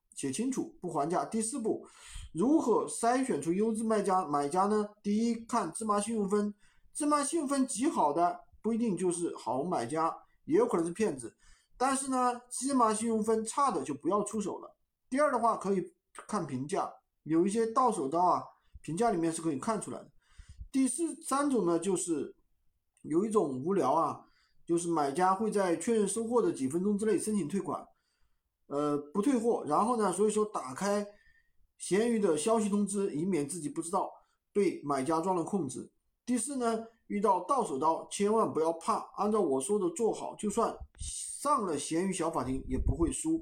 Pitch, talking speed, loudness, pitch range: 215 Hz, 270 characters per minute, -31 LUFS, 185-245 Hz